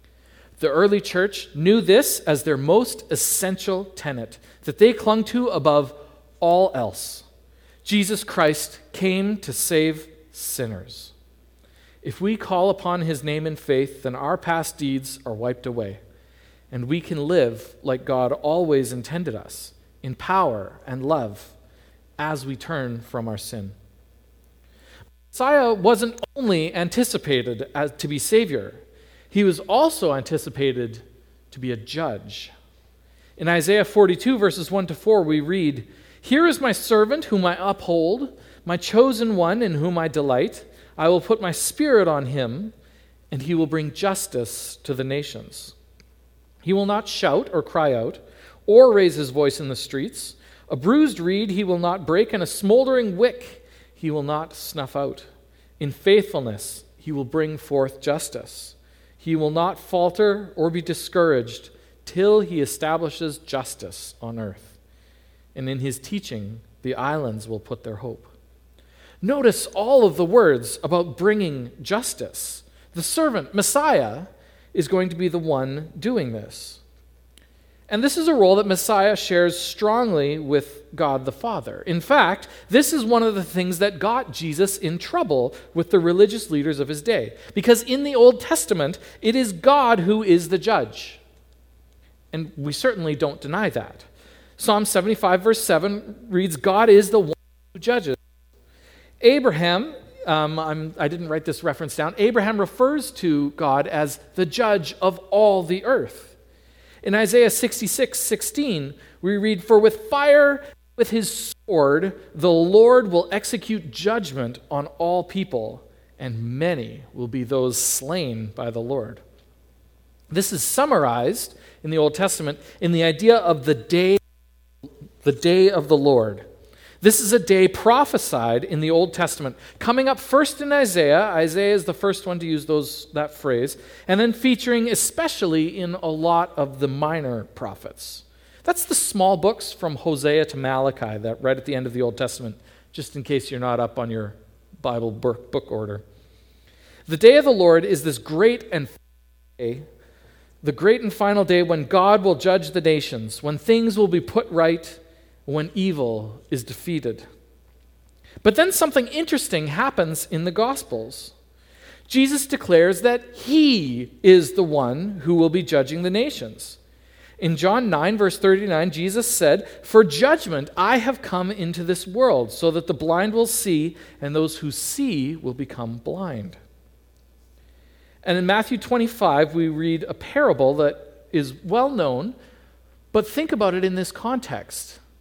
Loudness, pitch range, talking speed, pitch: -21 LUFS, 130-205 Hz, 155 wpm, 165 Hz